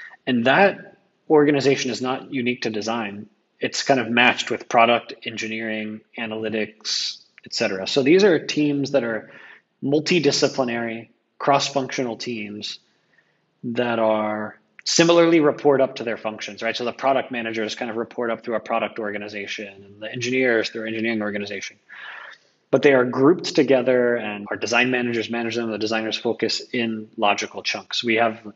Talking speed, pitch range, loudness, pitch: 155 wpm, 110-130 Hz, -21 LUFS, 115 Hz